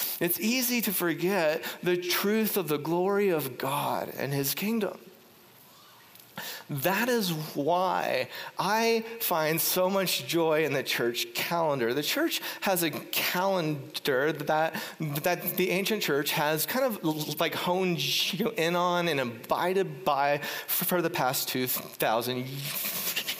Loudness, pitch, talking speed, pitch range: -28 LUFS, 175 Hz, 130 wpm, 150-195 Hz